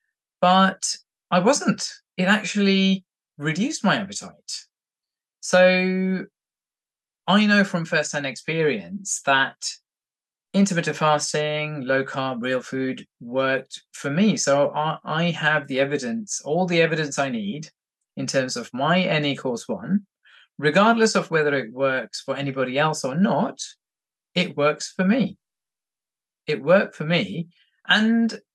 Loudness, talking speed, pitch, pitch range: -22 LUFS, 125 wpm, 165 Hz, 140-195 Hz